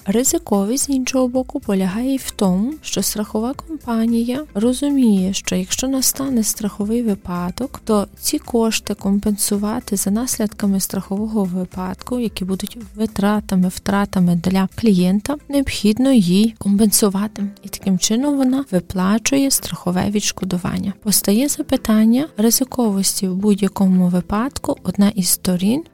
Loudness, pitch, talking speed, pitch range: -18 LUFS, 210 Hz, 115 wpm, 195-245 Hz